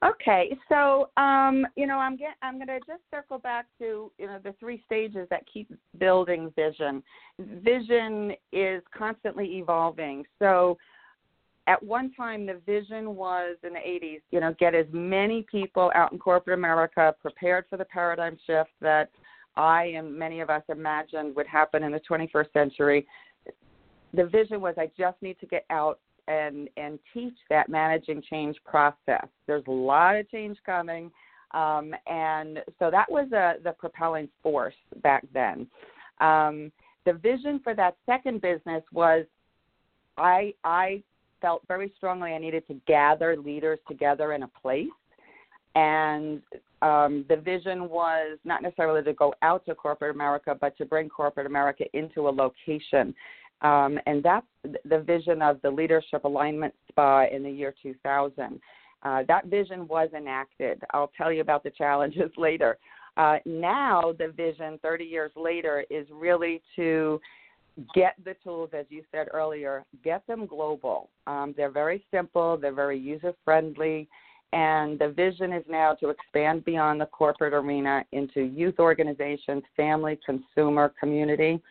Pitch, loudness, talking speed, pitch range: 160 Hz, -26 LUFS, 155 wpm, 150-185 Hz